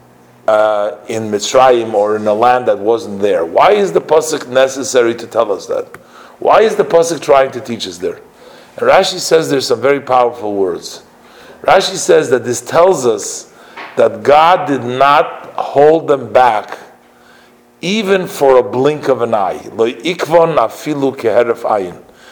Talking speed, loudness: 150 wpm, -12 LUFS